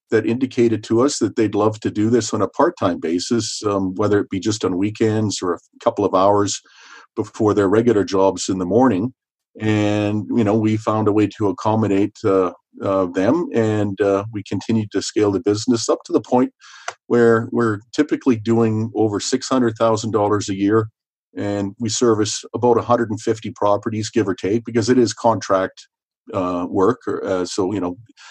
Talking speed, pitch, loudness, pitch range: 195 wpm, 110 Hz, -19 LUFS, 100-115 Hz